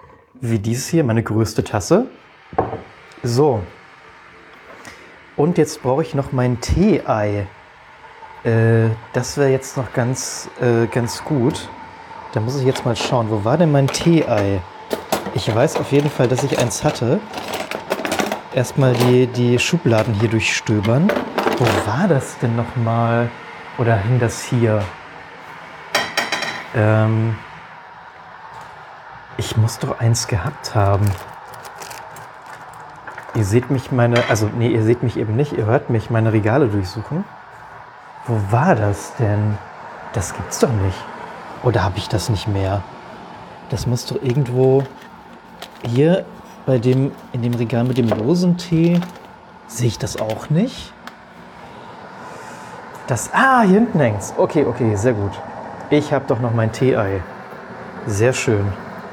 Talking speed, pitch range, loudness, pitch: 135 wpm, 110-135 Hz, -18 LUFS, 120 Hz